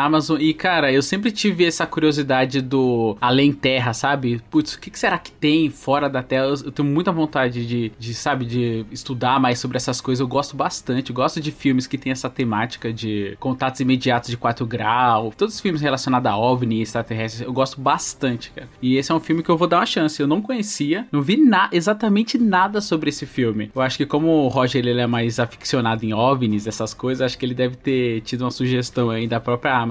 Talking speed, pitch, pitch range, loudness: 225 wpm, 130 Hz, 120-150 Hz, -20 LUFS